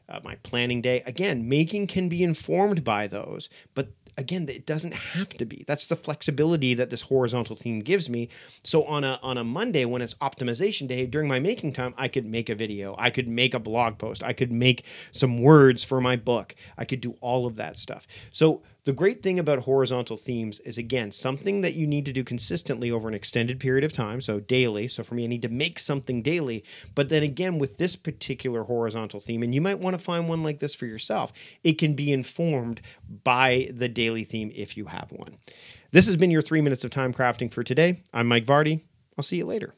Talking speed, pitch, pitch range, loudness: 225 wpm, 130 Hz, 115-150 Hz, -25 LUFS